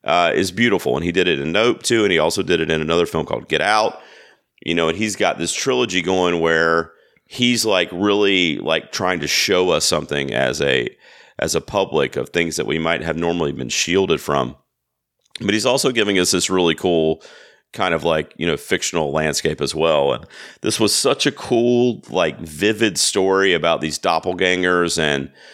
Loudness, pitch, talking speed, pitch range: -18 LUFS, 85 Hz, 195 wpm, 80-95 Hz